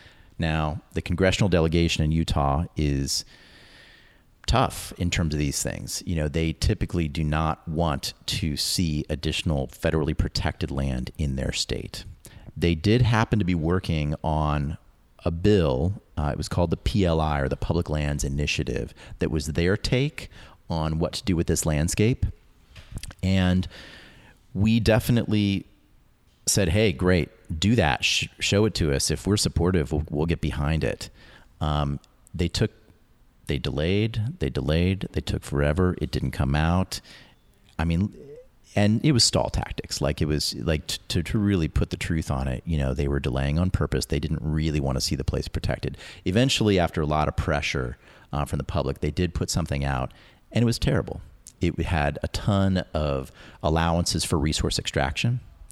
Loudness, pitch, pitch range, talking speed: -25 LUFS, 85 Hz, 75-95 Hz, 170 wpm